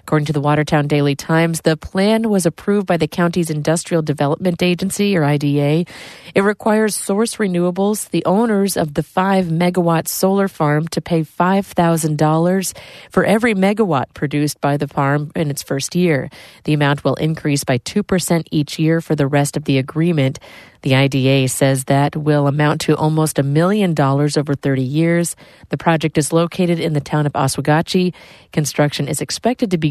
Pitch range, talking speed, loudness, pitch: 145-180 Hz, 175 wpm, -17 LUFS, 160 Hz